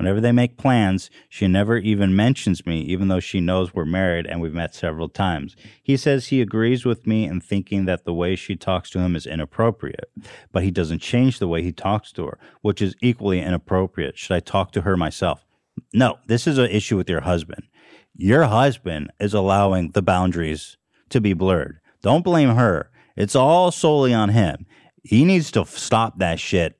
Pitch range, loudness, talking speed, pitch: 90-115 Hz, -20 LUFS, 195 wpm, 95 Hz